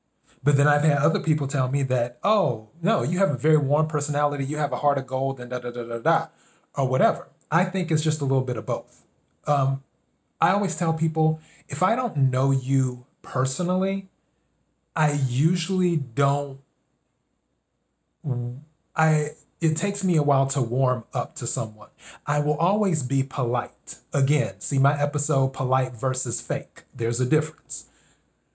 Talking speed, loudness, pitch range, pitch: 170 wpm, -24 LUFS, 130-155 Hz, 145 Hz